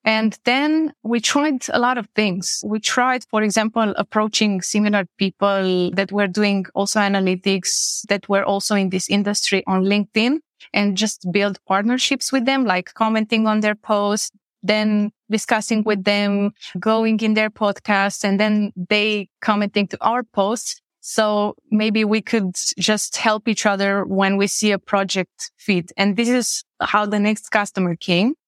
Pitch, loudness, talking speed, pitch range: 210 Hz, -19 LUFS, 160 wpm, 200-220 Hz